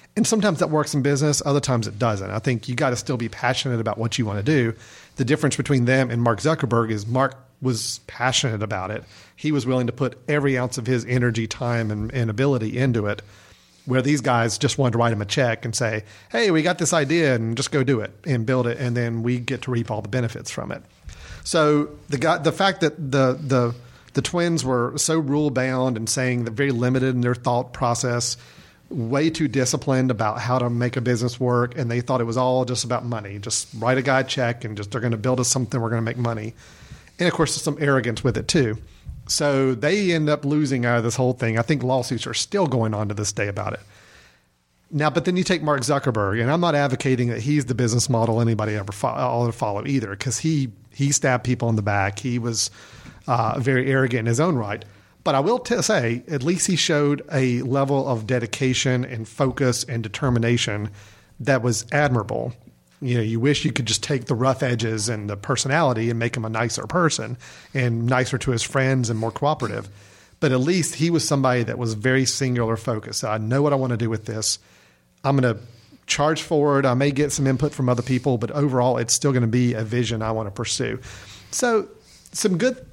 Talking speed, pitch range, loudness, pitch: 230 wpm, 115-140 Hz, -22 LUFS, 125 Hz